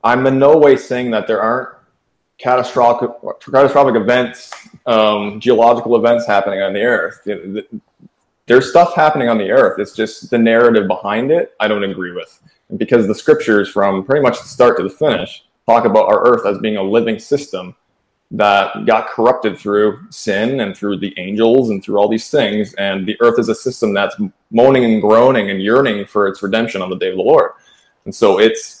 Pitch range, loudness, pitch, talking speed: 105-135 Hz, -14 LUFS, 115 Hz, 190 wpm